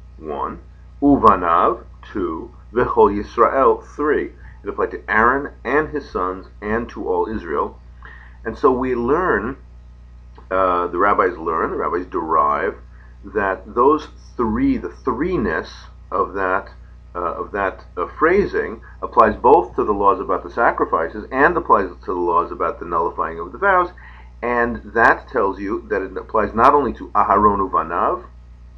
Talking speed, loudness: 150 wpm, -19 LUFS